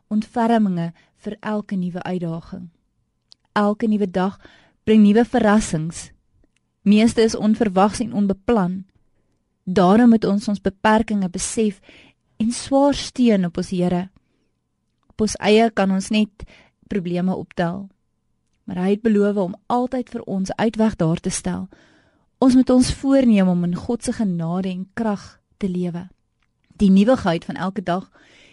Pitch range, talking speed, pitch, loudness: 185-225 Hz, 135 wpm, 205 Hz, -20 LUFS